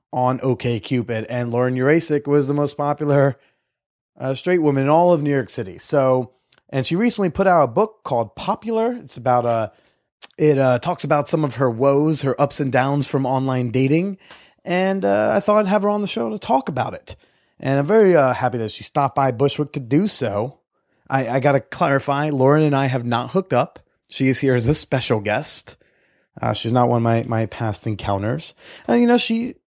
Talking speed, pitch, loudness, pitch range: 210 wpm, 135 Hz, -19 LUFS, 125-155 Hz